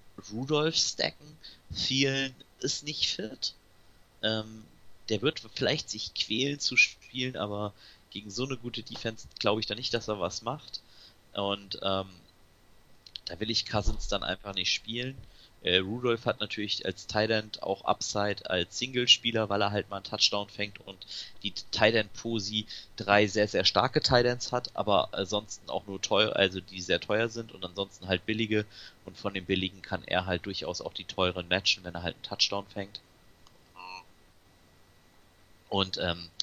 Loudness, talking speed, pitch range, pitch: -30 LUFS, 160 wpm, 95-110 Hz, 100 Hz